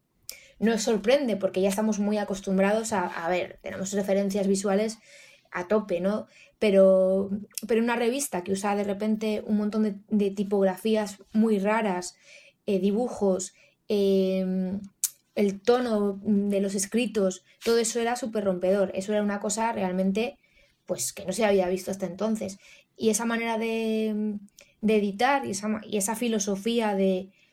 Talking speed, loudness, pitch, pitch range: 150 wpm, -26 LUFS, 205 Hz, 195-220 Hz